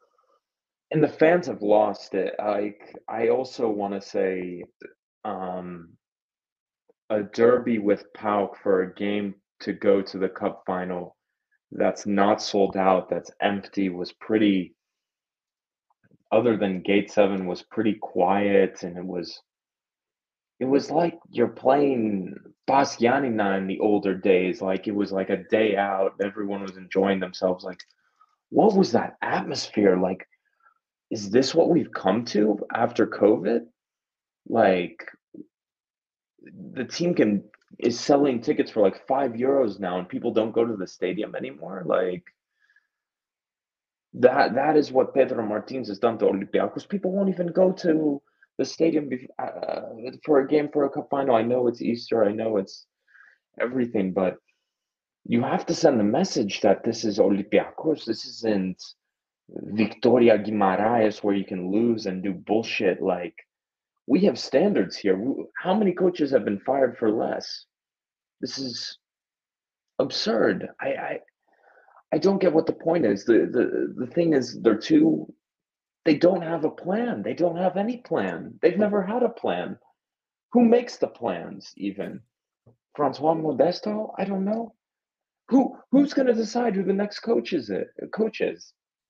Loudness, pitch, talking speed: -24 LUFS, 120 Hz, 150 wpm